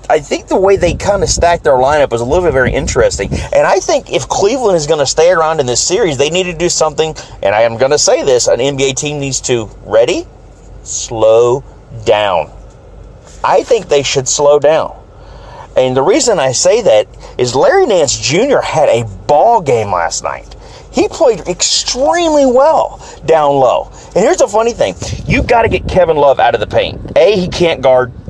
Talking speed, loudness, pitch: 205 wpm, -11 LUFS, 155 Hz